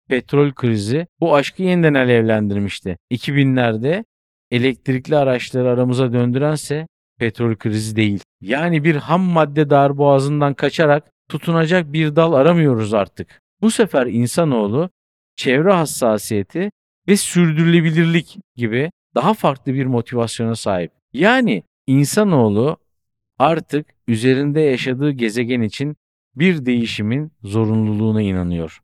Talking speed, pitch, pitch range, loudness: 100 wpm, 135 Hz, 115-160 Hz, -17 LUFS